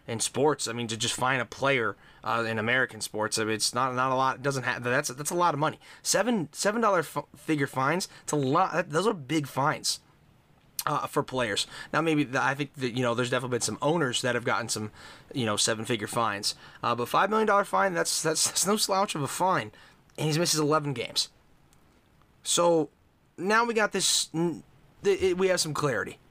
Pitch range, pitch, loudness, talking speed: 120-170 Hz, 145 Hz, -27 LUFS, 220 wpm